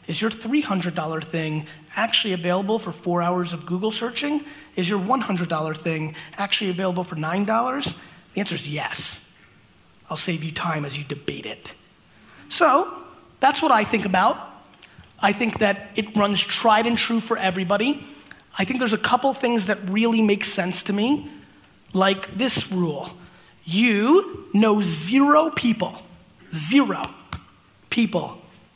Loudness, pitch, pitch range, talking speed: -21 LUFS, 200 Hz, 175-230 Hz, 145 wpm